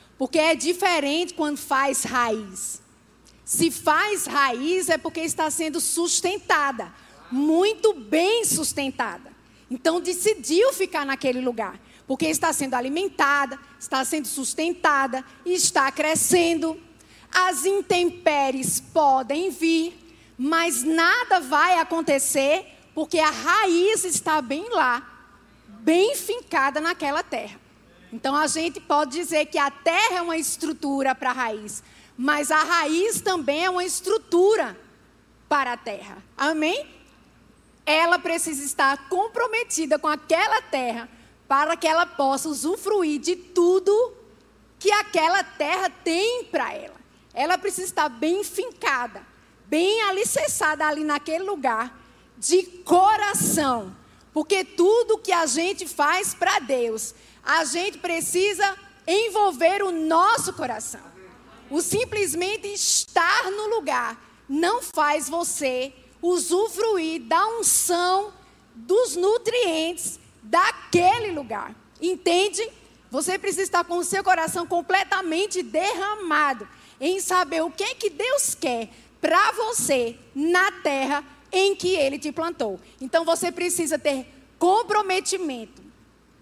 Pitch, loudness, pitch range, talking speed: 330 Hz, -23 LUFS, 290-375 Hz, 115 wpm